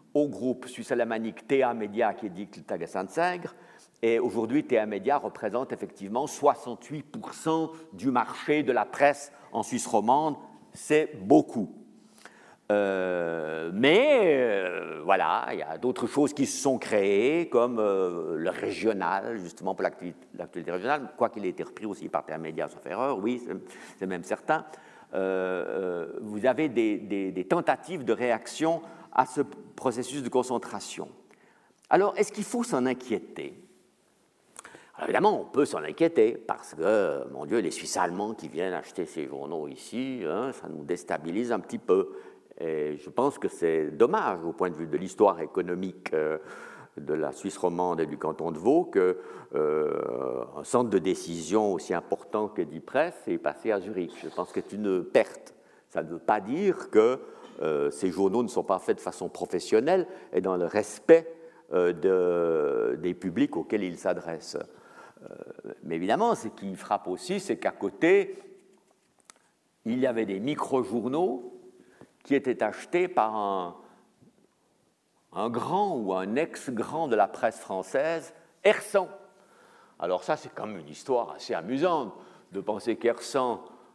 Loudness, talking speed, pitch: -28 LUFS, 160 wpm, 165 Hz